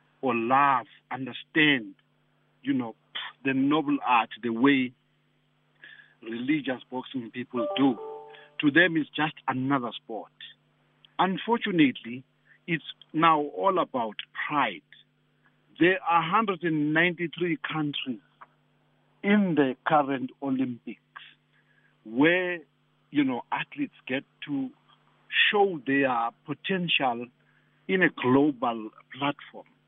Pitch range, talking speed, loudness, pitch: 130-190 Hz, 95 wpm, -26 LUFS, 150 Hz